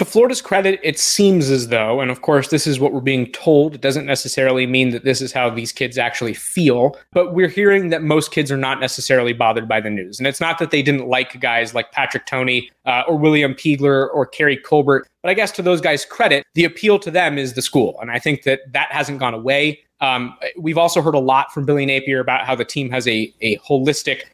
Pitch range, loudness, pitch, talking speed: 130-155 Hz, -17 LUFS, 135 Hz, 240 wpm